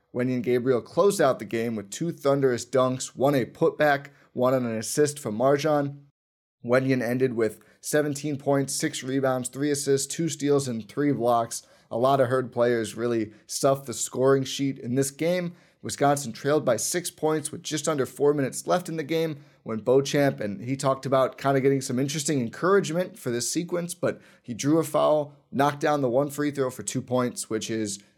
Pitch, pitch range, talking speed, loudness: 135 Hz, 125-150 Hz, 195 wpm, -25 LUFS